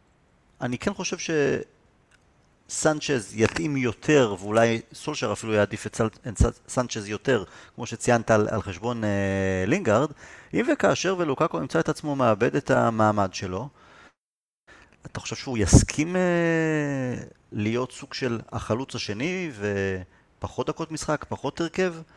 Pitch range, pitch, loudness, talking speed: 105-155 Hz, 125 Hz, -25 LUFS, 120 wpm